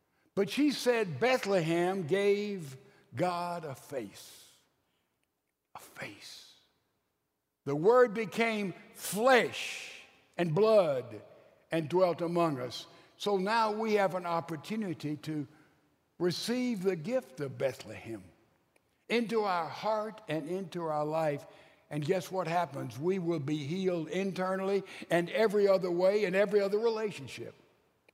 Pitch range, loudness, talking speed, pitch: 160-210 Hz, -31 LUFS, 120 wpm, 185 Hz